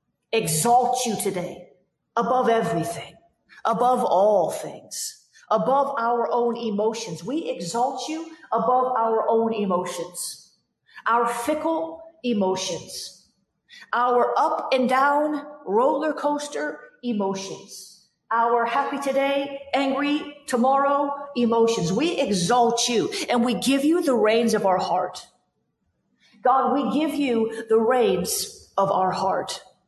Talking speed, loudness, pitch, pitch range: 110 wpm, -23 LUFS, 245 Hz, 225-285 Hz